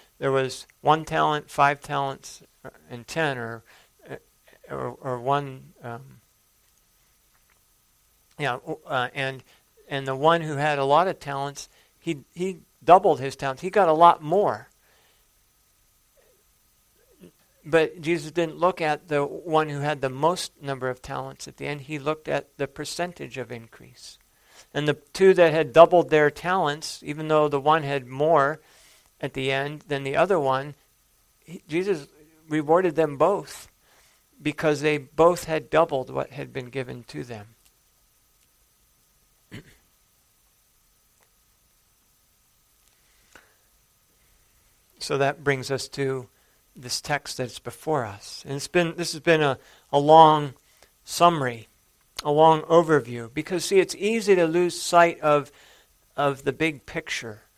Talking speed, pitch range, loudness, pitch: 135 wpm, 135-160 Hz, -23 LUFS, 150 Hz